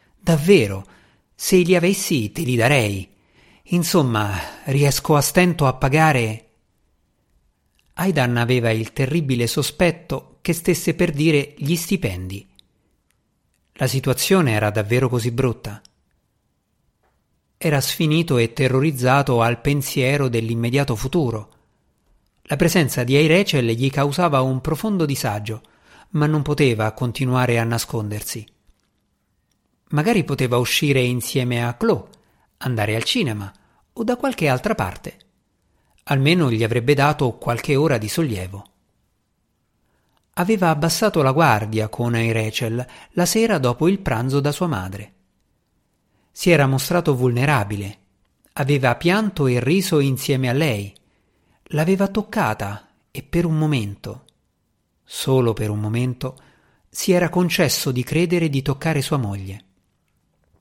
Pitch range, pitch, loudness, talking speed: 110-155 Hz, 130 Hz, -19 LUFS, 120 wpm